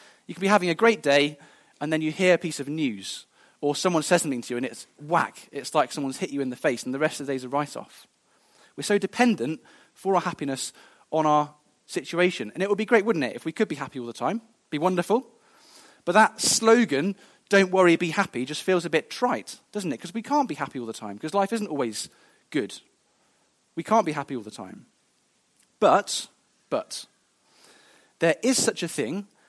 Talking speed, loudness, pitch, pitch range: 220 wpm, -25 LUFS, 170 Hz, 145-215 Hz